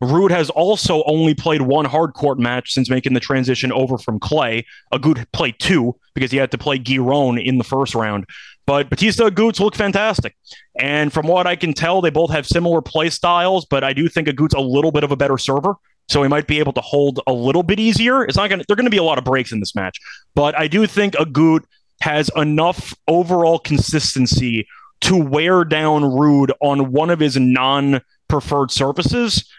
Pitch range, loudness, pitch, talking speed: 135-170 Hz, -17 LUFS, 150 Hz, 205 wpm